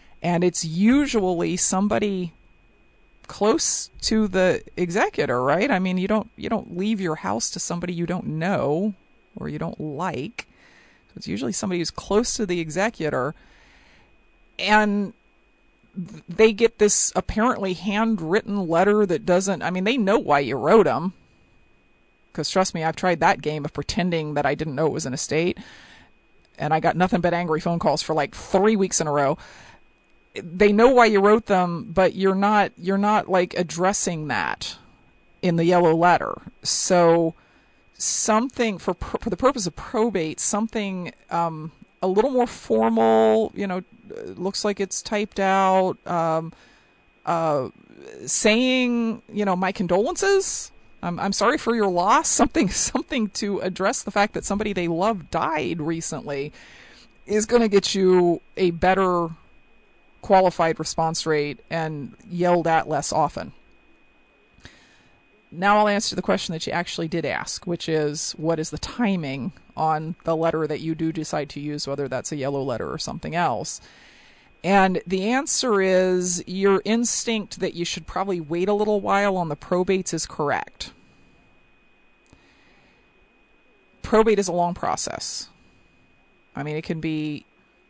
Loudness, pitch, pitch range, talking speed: -22 LUFS, 185 Hz, 165-210 Hz, 155 wpm